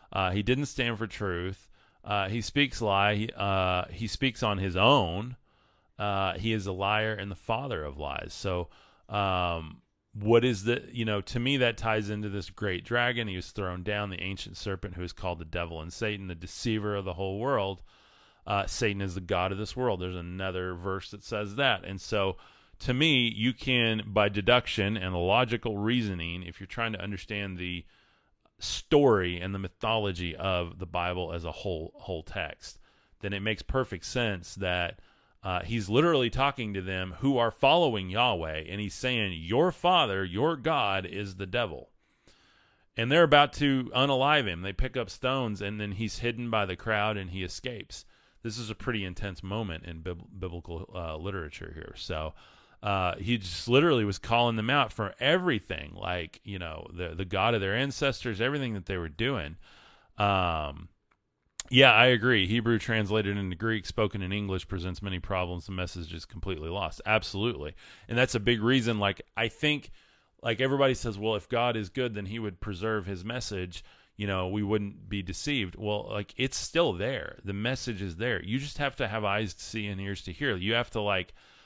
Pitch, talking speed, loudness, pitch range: 105 Hz, 190 wpm, -29 LUFS, 95-115 Hz